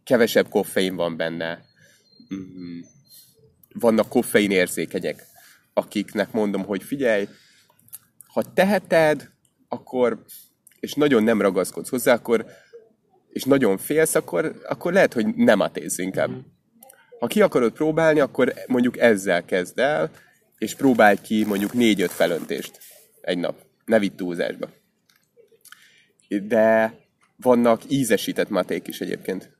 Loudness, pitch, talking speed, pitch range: -21 LUFS, 110 Hz, 120 wpm, 100-155 Hz